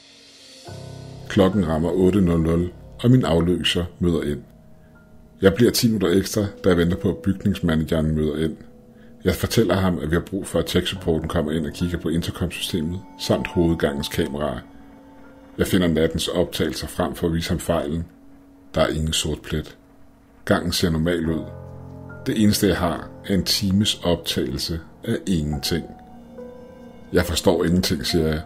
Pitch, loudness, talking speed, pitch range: 90 Hz, -22 LUFS, 155 wpm, 80-100 Hz